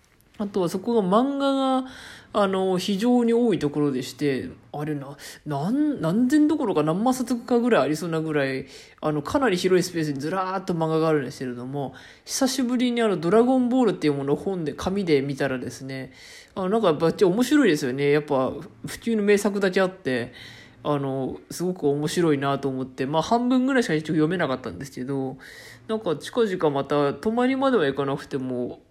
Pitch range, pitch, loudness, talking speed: 140-225 Hz, 160 Hz, -24 LUFS, 395 characters per minute